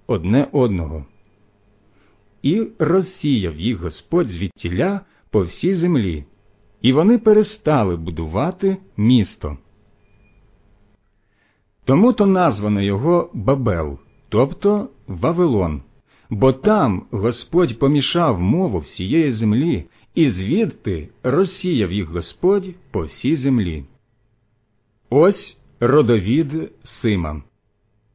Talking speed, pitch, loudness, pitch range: 85 wpm, 115 Hz, -19 LUFS, 100-160 Hz